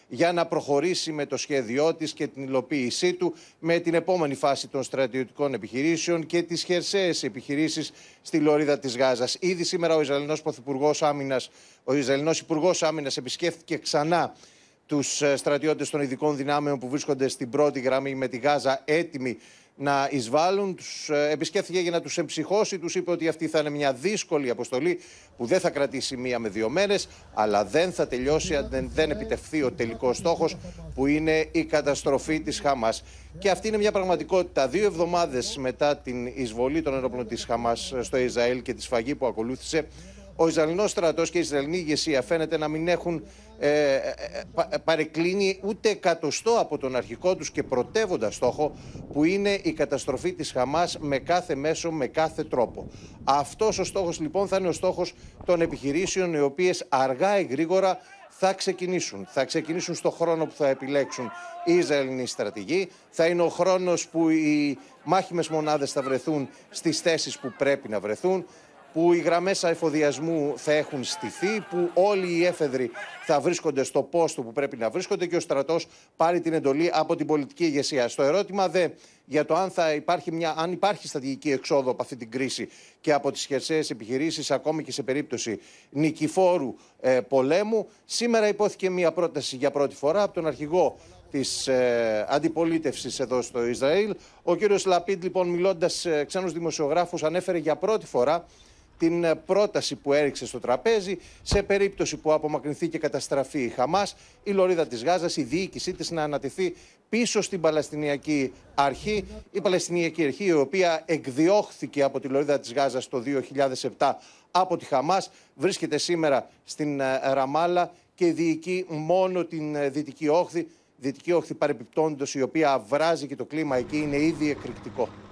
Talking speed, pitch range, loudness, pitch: 165 wpm, 135-175 Hz, -26 LUFS, 155 Hz